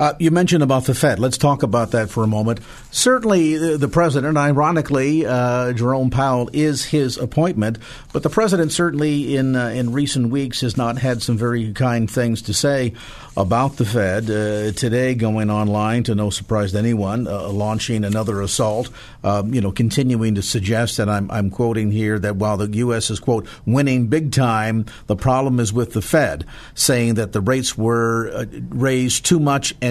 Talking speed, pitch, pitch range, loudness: 190 wpm, 120 Hz, 110-135 Hz, -19 LUFS